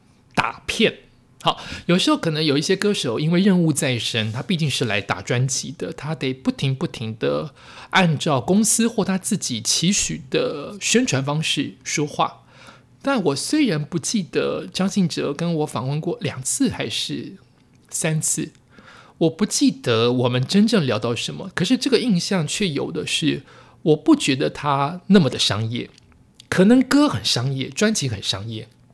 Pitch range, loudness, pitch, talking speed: 130-195 Hz, -21 LUFS, 160 Hz, 240 characters per minute